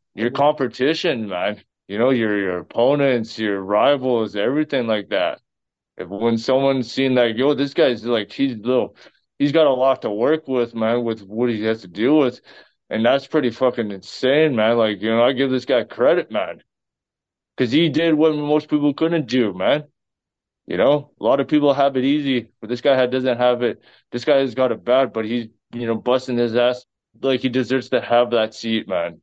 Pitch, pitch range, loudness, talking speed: 125 Hz, 115-135 Hz, -19 LUFS, 205 wpm